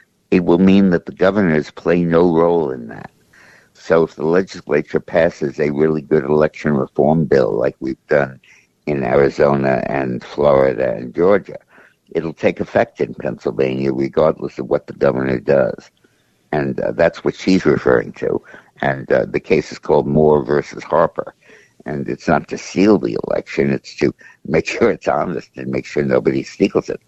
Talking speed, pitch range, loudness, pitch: 170 wpm, 65-80 Hz, -17 LUFS, 70 Hz